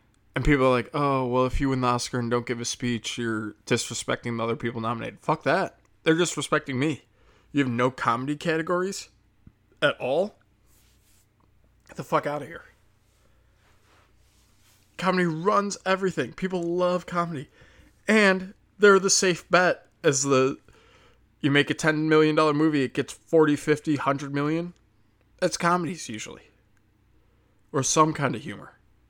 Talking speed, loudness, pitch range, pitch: 150 wpm, -25 LUFS, 110-160 Hz, 130 Hz